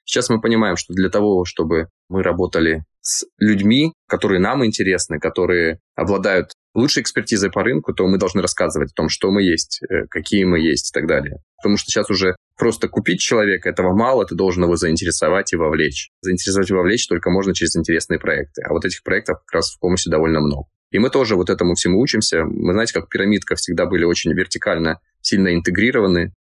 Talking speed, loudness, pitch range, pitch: 195 wpm, -18 LUFS, 85-95 Hz, 90 Hz